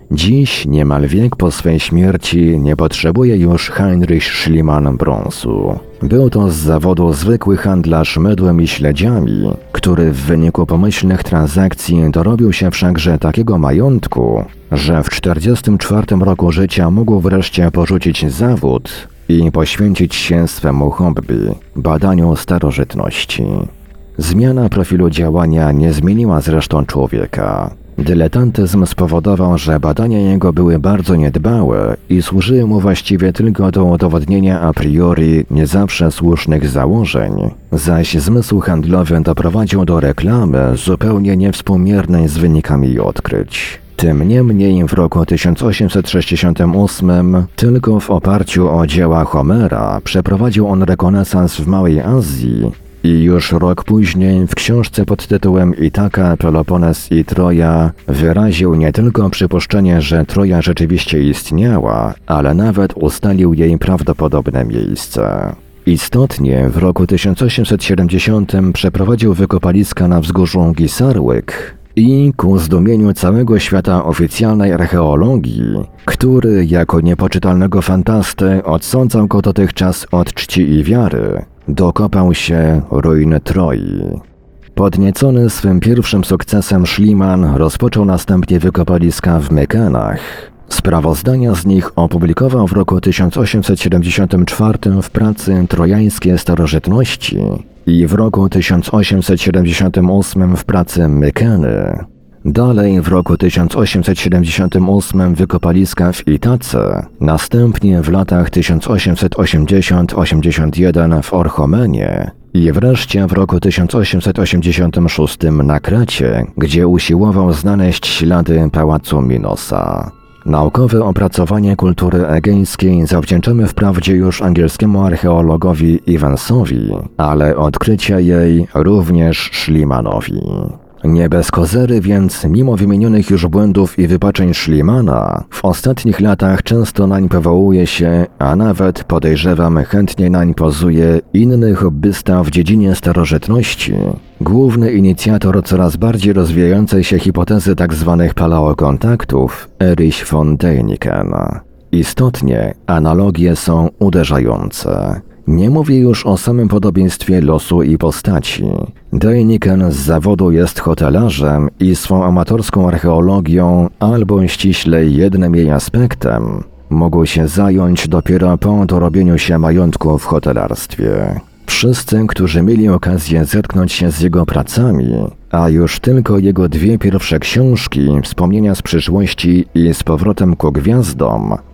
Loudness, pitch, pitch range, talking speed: -11 LUFS, 90 Hz, 80-100 Hz, 110 wpm